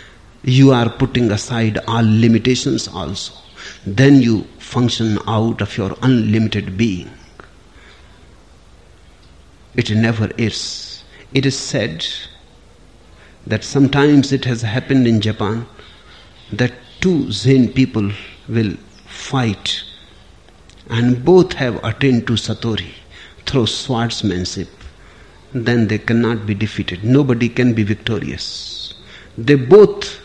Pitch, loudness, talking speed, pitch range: 110 Hz, -16 LUFS, 105 wpm, 95-125 Hz